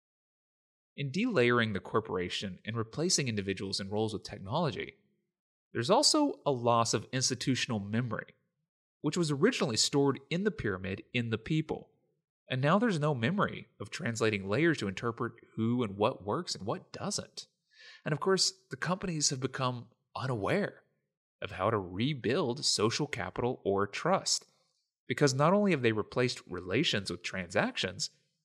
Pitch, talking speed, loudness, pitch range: 130 Hz, 150 wpm, -31 LUFS, 110-160 Hz